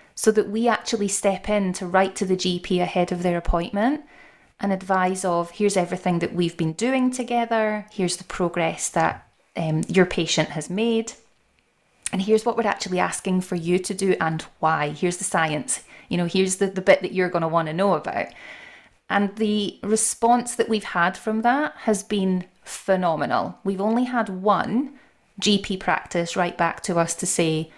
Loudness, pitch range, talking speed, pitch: -23 LUFS, 175-215 Hz, 185 wpm, 190 Hz